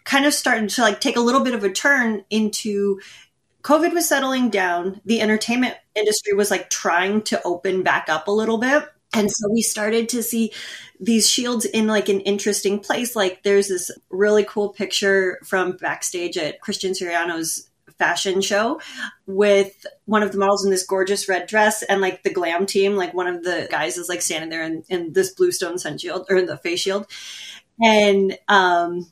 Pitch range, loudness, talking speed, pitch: 185-220 Hz, -20 LUFS, 190 wpm, 200 Hz